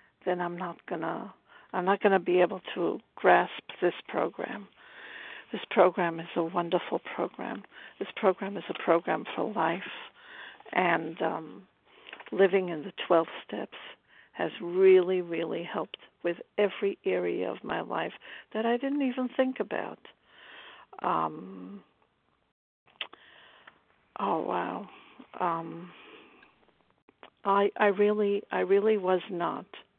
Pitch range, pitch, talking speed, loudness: 175-210 Hz, 185 Hz, 125 wpm, -29 LUFS